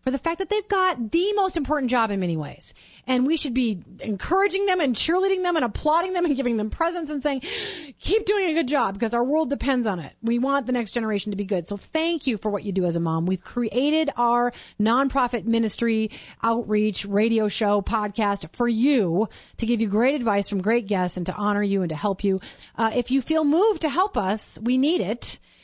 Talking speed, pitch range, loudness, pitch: 230 wpm, 210-310 Hz, -23 LUFS, 240 Hz